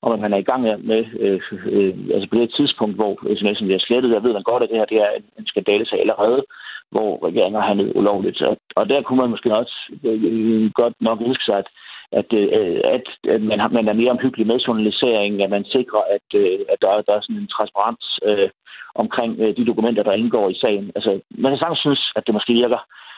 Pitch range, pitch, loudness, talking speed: 110-165 Hz, 120 Hz, -19 LUFS, 235 wpm